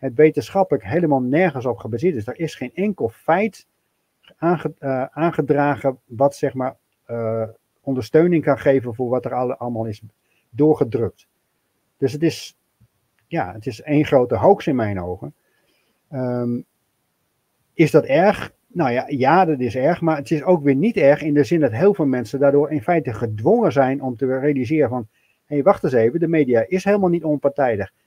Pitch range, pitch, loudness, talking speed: 120-160 Hz, 140 Hz, -19 LUFS, 170 wpm